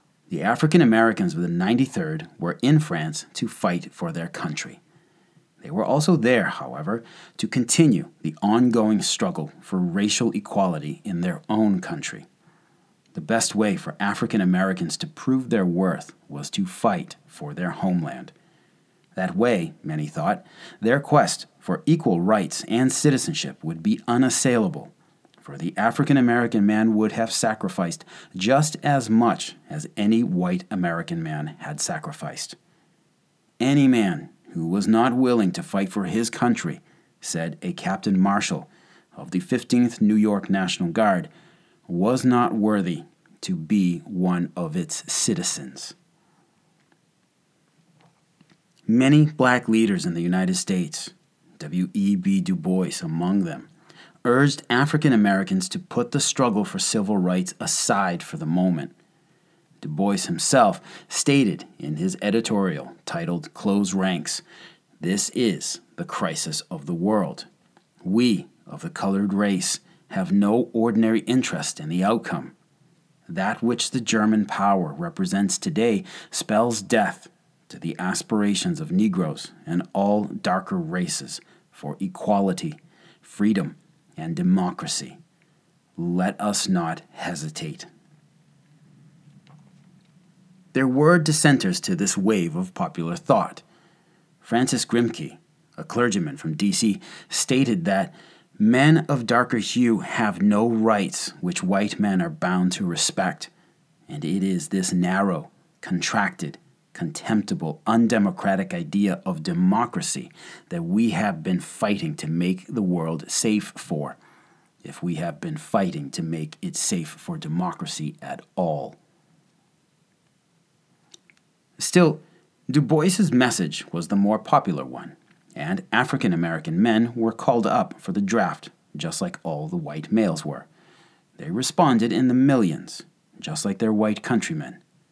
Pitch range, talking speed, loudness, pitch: 105-175 Hz, 130 wpm, -23 LUFS, 140 Hz